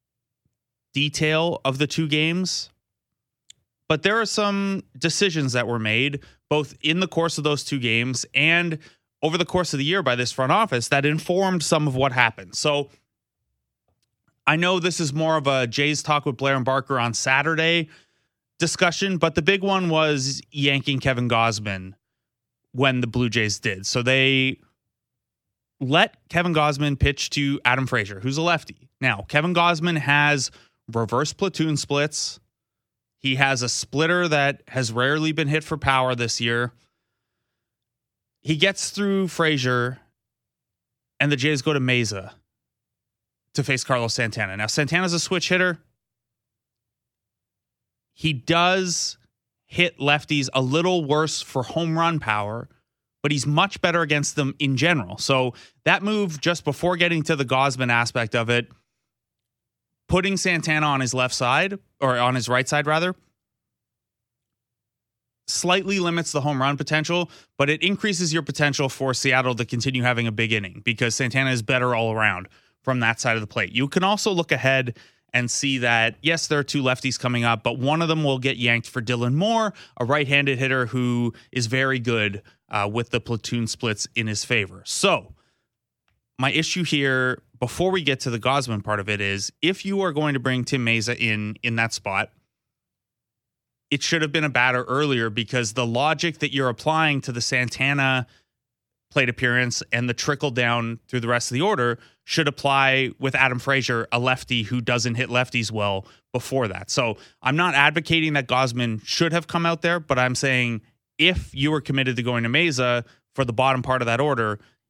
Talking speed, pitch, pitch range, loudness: 175 wpm, 130 Hz, 120-155 Hz, -22 LUFS